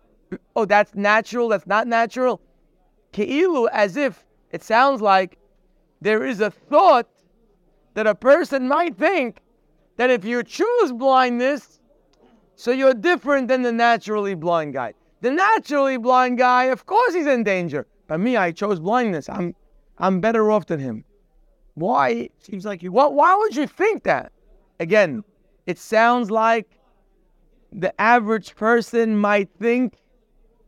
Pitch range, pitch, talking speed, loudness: 200-255 Hz, 225 Hz, 140 wpm, -19 LUFS